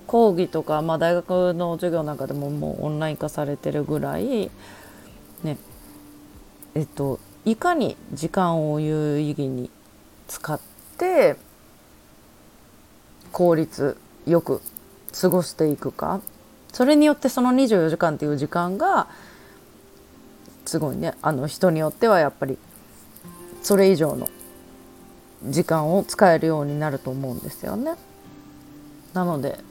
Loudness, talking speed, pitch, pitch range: -23 LUFS, 240 characters per minute, 160 Hz, 145-180 Hz